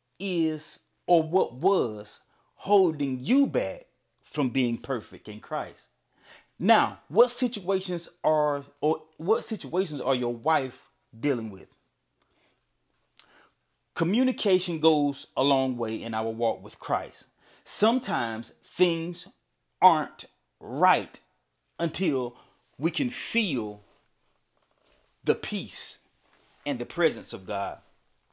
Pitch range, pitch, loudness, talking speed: 120-190 Hz, 155 Hz, -27 LUFS, 105 wpm